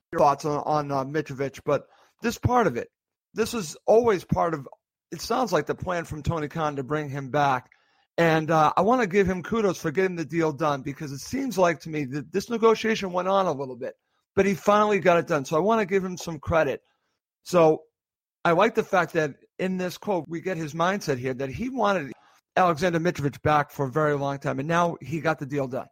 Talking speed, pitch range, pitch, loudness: 235 wpm, 150-195 Hz, 165 Hz, -25 LUFS